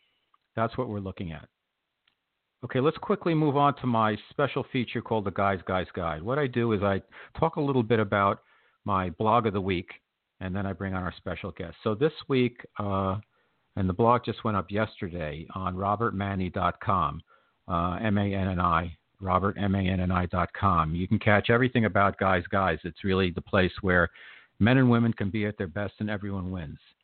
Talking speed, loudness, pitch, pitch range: 190 wpm, -27 LUFS, 100 Hz, 95-115 Hz